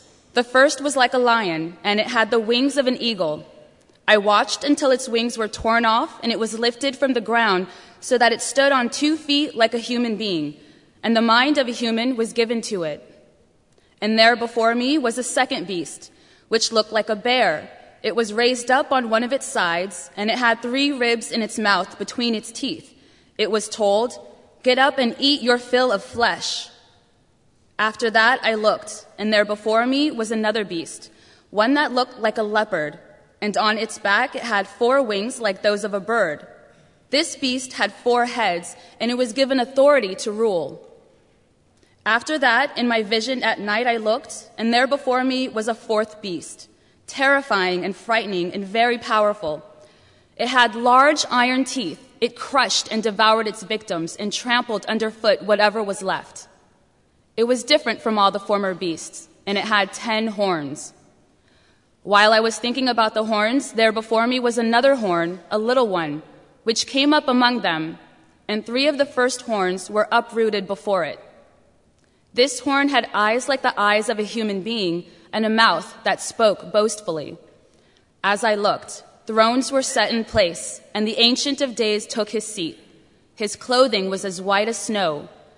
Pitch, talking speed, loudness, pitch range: 225 Hz, 180 wpm, -20 LUFS, 210-250 Hz